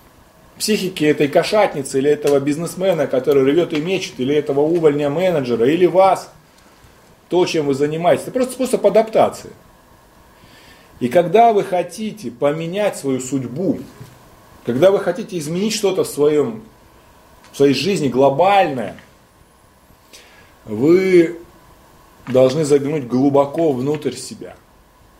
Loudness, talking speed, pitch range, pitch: -17 LUFS, 110 wpm, 140-185 Hz, 155 Hz